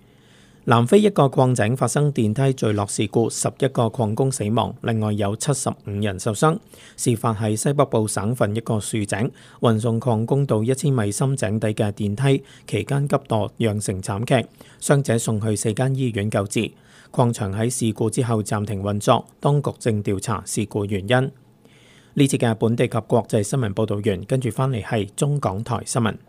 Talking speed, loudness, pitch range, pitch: 265 characters per minute, -22 LUFS, 110-130 Hz, 115 Hz